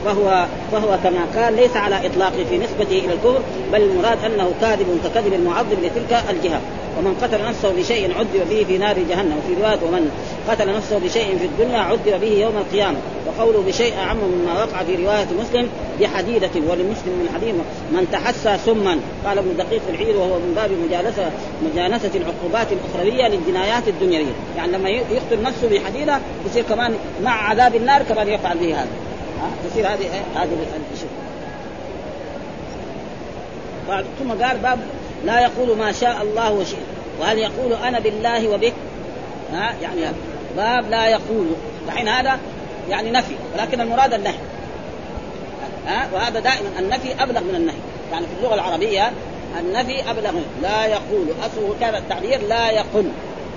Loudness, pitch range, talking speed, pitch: -19 LUFS, 200-245 Hz, 150 wpm, 220 Hz